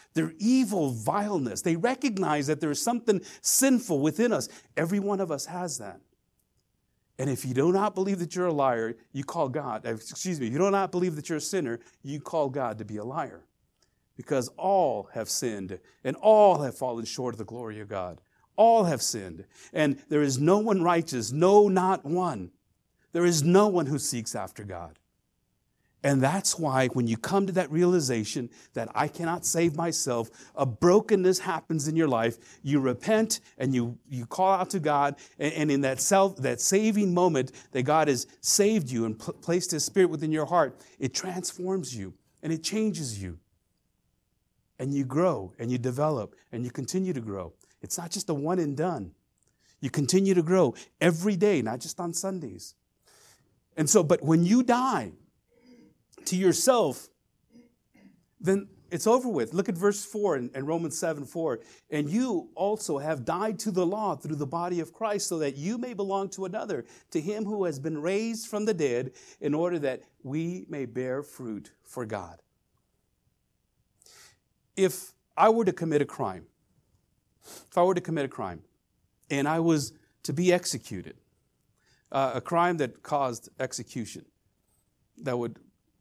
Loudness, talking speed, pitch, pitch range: -27 LUFS, 175 wpm, 160 Hz, 130-190 Hz